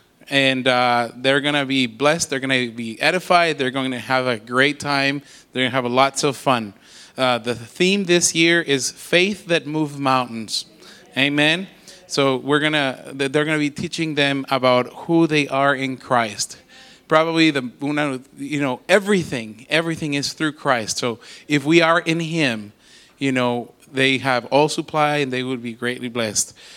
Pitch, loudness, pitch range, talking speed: 140 Hz, -19 LUFS, 125-155 Hz, 160 wpm